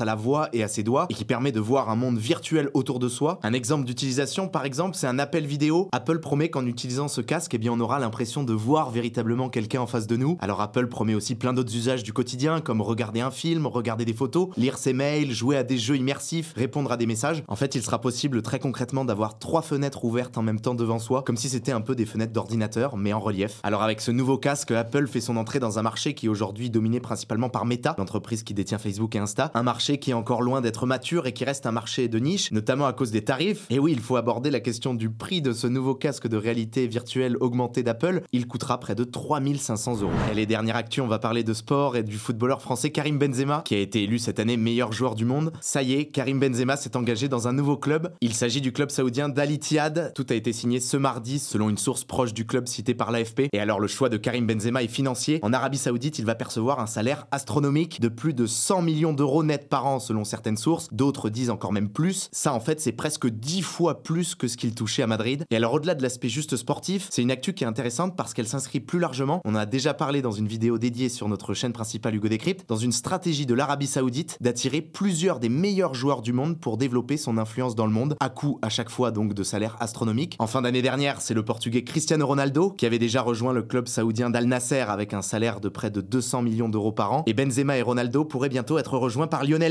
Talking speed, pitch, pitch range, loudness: 255 wpm, 125 Hz, 115-140 Hz, -26 LUFS